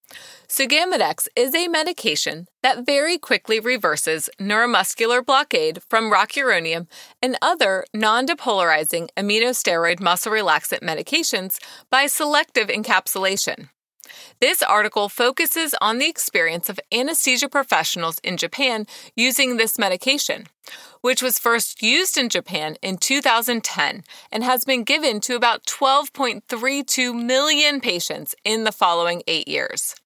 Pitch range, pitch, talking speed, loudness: 195-275 Hz, 240 Hz, 120 wpm, -19 LUFS